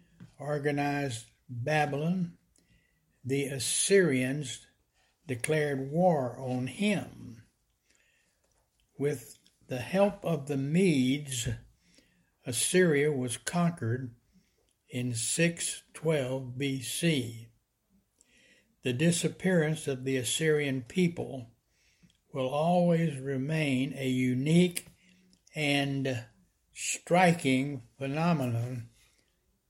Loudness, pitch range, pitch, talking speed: -30 LUFS, 125-165 Hz, 140 Hz, 70 wpm